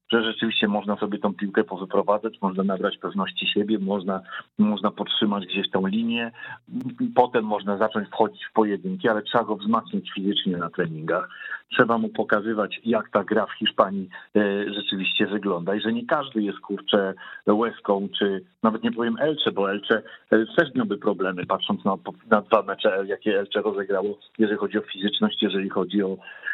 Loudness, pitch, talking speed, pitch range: -24 LUFS, 105 Hz, 165 wpm, 100-110 Hz